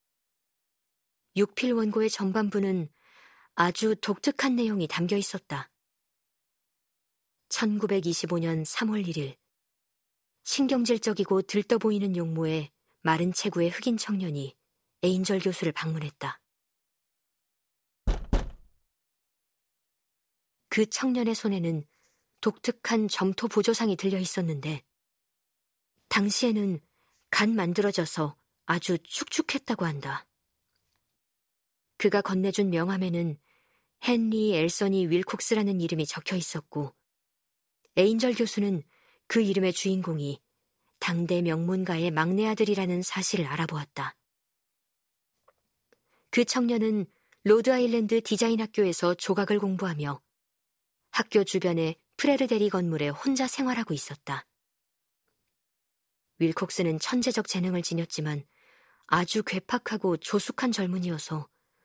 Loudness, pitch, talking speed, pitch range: -28 LUFS, 190 Hz, 230 characters per minute, 165-220 Hz